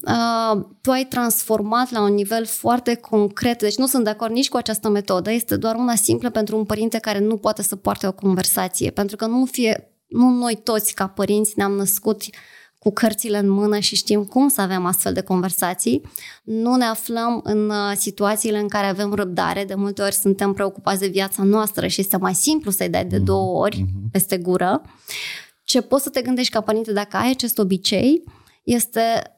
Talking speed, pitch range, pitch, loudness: 190 wpm, 200-230 Hz, 215 Hz, -20 LUFS